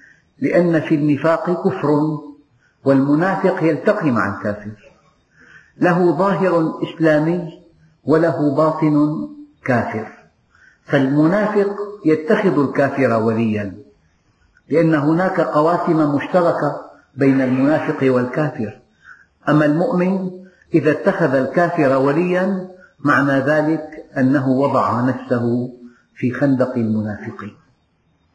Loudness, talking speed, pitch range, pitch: -17 LUFS, 85 wpm, 130-170 Hz, 150 Hz